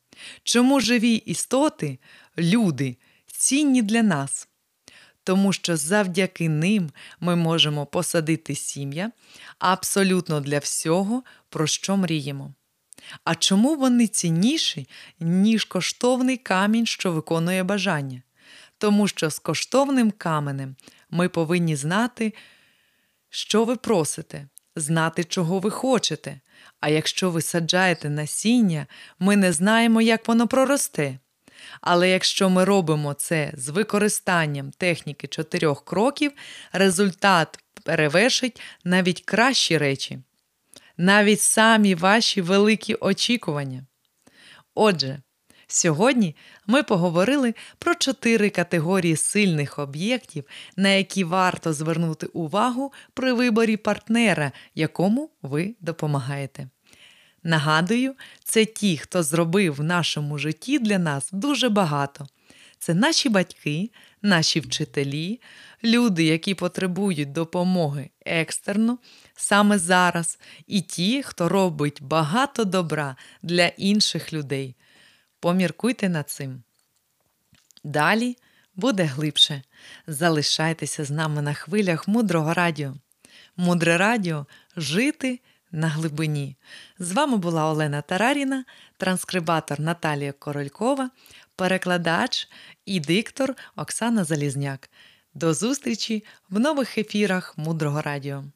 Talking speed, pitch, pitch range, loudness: 100 wpm, 180 Hz, 155-215 Hz, -22 LUFS